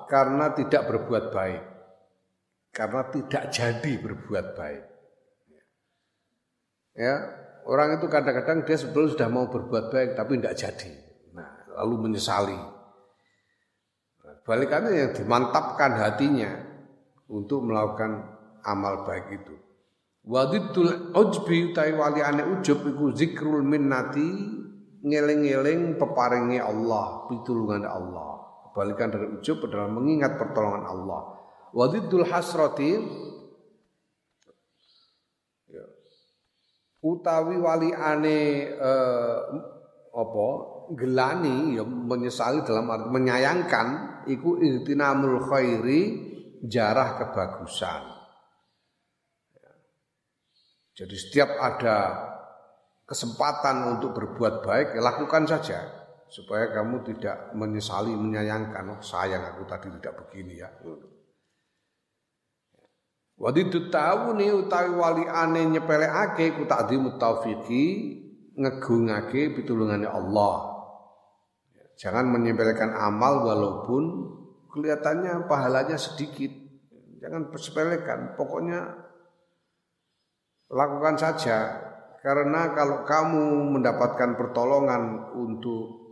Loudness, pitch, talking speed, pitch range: -26 LUFS, 135 Hz, 85 wpm, 110-155 Hz